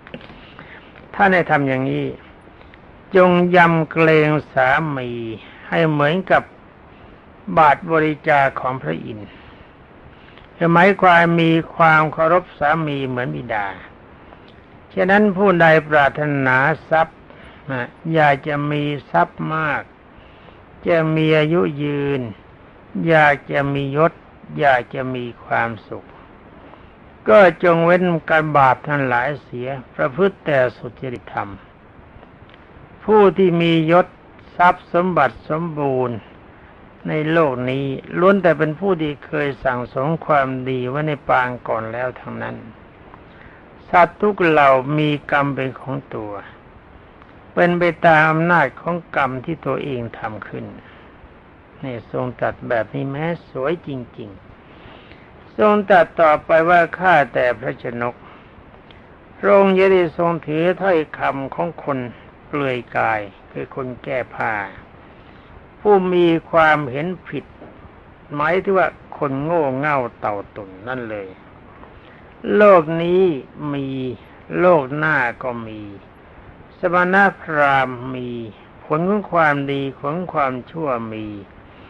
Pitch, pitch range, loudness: 150 Hz, 130-170 Hz, -17 LUFS